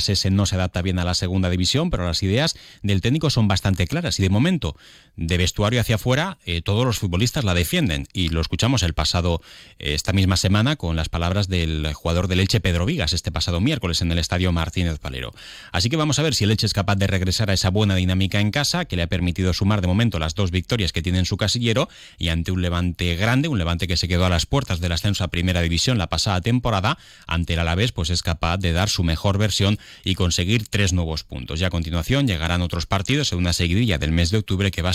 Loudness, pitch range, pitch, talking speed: -21 LUFS, 85-105 Hz, 95 Hz, 240 wpm